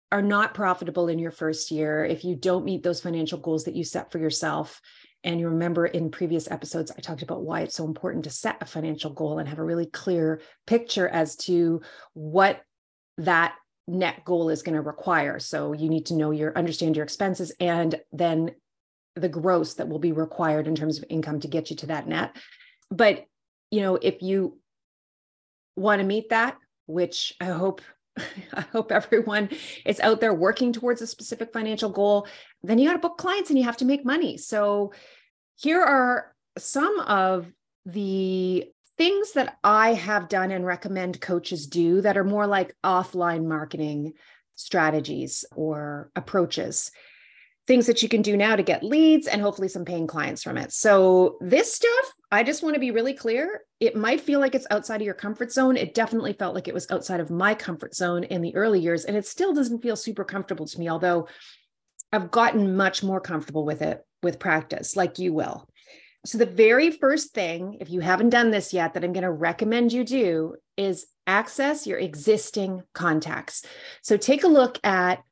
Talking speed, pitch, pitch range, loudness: 190 wpm, 185 Hz, 170-225 Hz, -24 LUFS